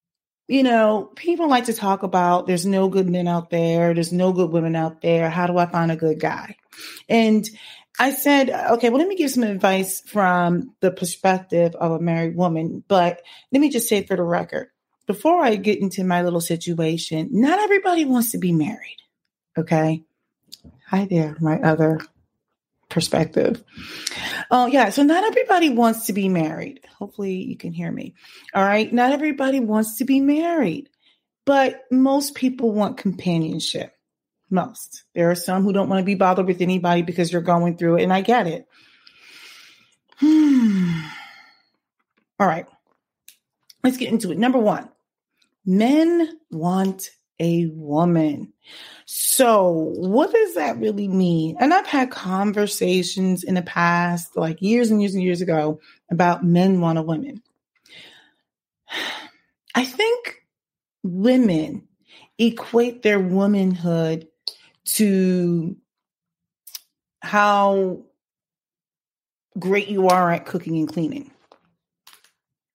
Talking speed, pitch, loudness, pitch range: 140 wpm, 190 Hz, -20 LUFS, 175-245 Hz